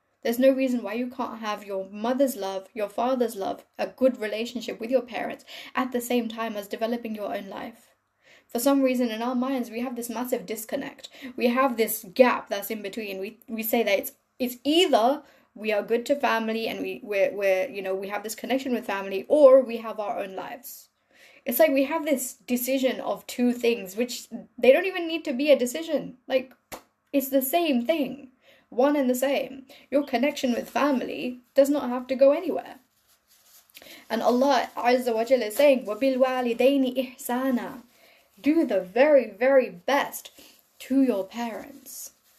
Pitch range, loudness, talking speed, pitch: 225-270 Hz, -25 LUFS, 180 wpm, 250 Hz